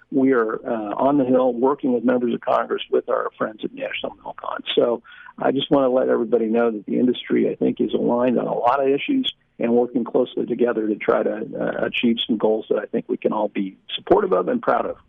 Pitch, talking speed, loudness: 130 Hz, 245 wpm, -21 LUFS